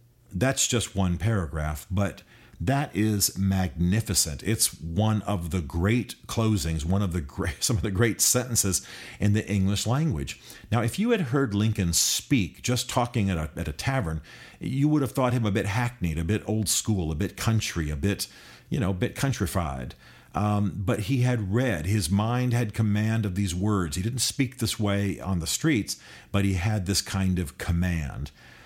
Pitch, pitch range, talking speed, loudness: 105 Hz, 95-120 Hz, 190 wpm, -26 LUFS